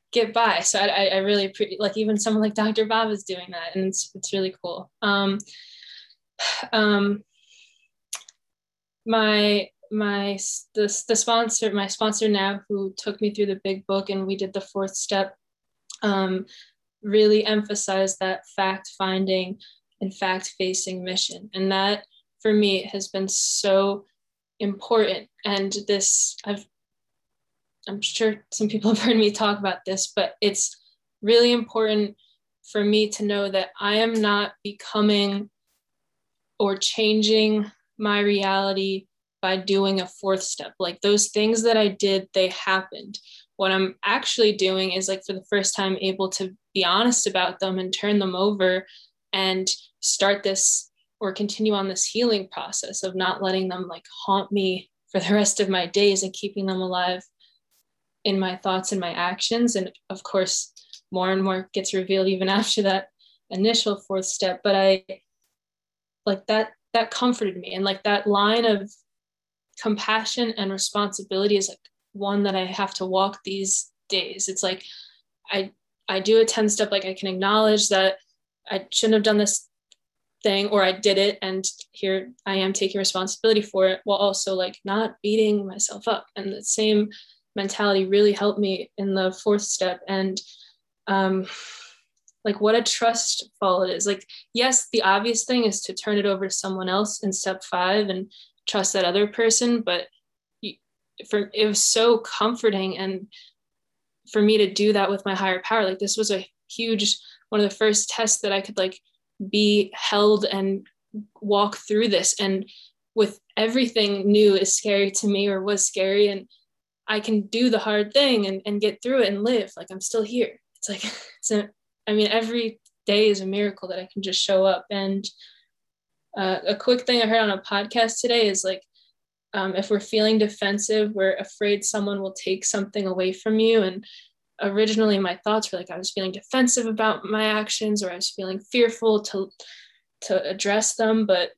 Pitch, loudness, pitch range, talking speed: 200 Hz, -23 LUFS, 190-215 Hz, 170 wpm